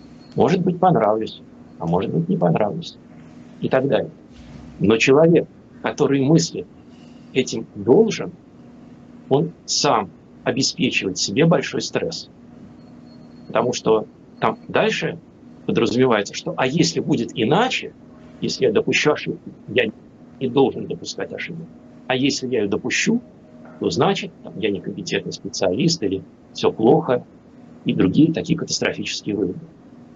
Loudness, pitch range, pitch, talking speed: -20 LUFS, 115-160 Hz, 130 Hz, 120 wpm